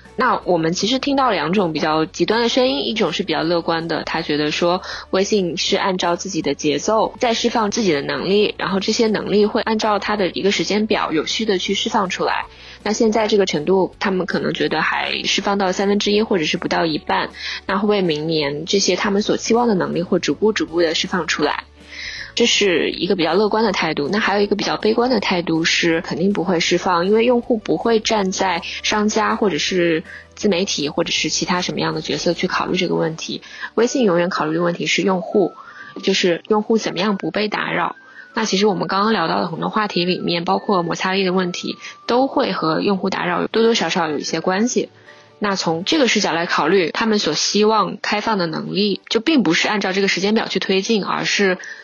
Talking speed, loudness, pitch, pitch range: 330 characters per minute, -18 LUFS, 195 Hz, 175-215 Hz